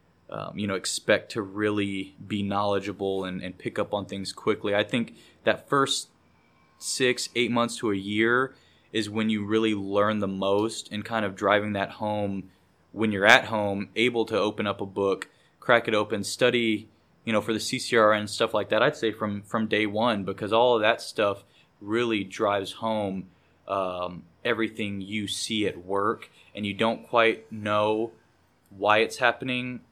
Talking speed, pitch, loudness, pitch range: 180 wpm, 105 Hz, -26 LUFS, 100-115 Hz